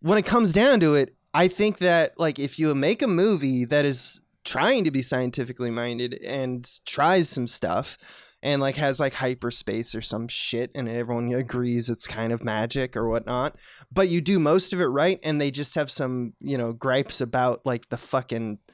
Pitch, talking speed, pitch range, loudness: 130 Hz, 200 wpm, 120-150 Hz, -24 LUFS